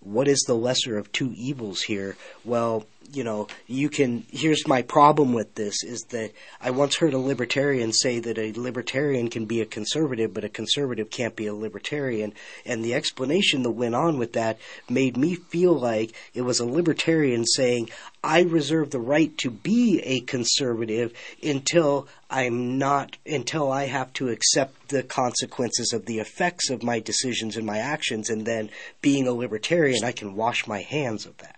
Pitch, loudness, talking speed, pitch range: 125 Hz, -24 LUFS, 180 wpm, 115-140 Hz